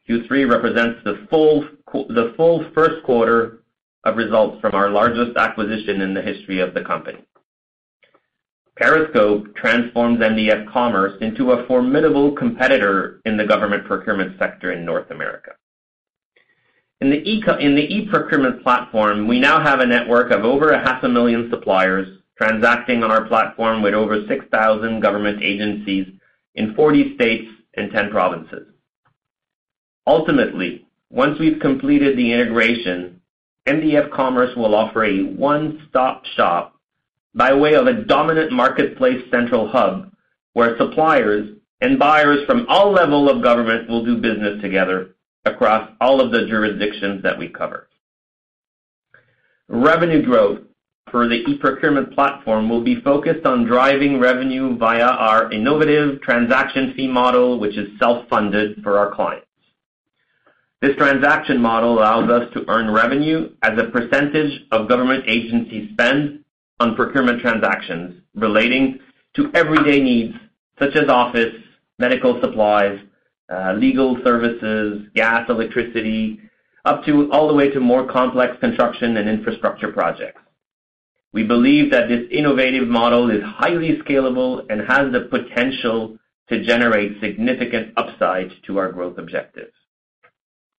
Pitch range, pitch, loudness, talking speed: 110-140 Hz, 120 Hz, -17 LUFS, 135 wpm